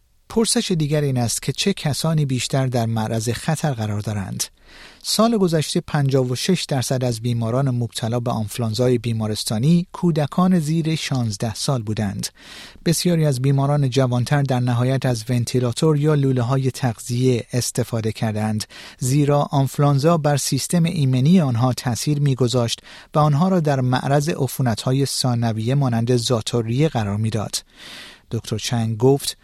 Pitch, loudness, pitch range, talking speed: 130 Hz, -20 LUFS, 120-150 Hz, 130 wpm